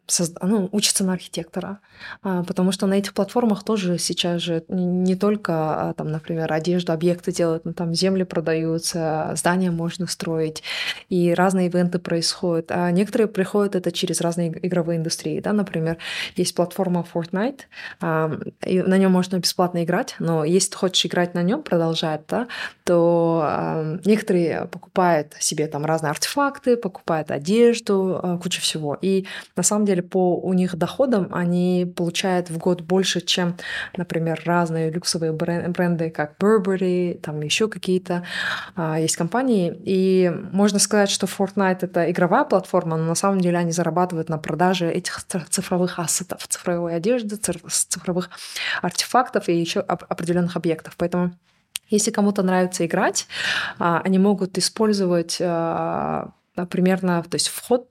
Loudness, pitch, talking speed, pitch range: -22 LUFS, 180 Hz, 145 wpm, 170-195 Hz